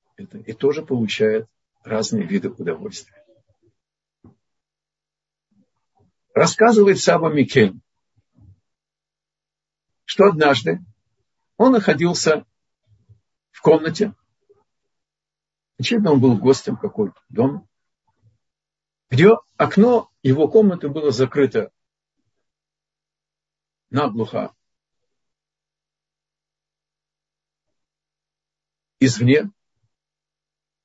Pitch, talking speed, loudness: 155 Hz, 60 wpm, -18 LUFS